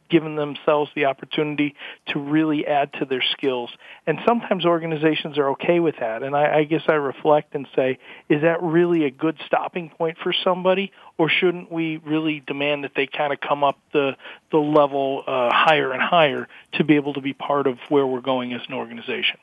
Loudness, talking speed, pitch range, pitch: -21 LUFS, 200 wpm, 140-165 Hz, 150 Hz